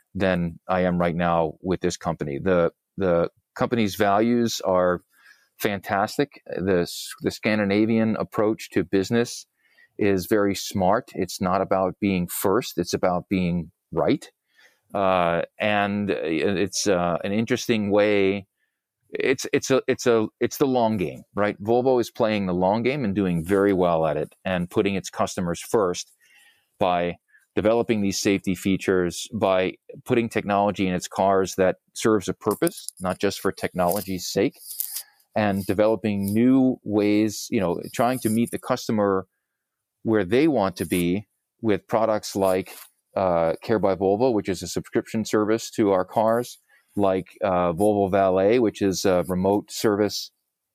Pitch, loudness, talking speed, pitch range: 100 Hz, -23 LUFS, 150 wpm, 90-110 Hz